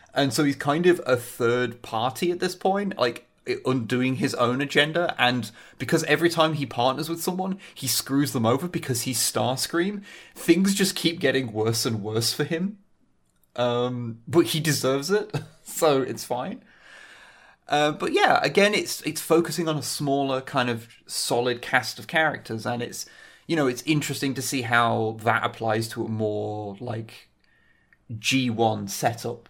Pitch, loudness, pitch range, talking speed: 130 Hz, -24 LUFS, 120-160 Hz, 165 wpm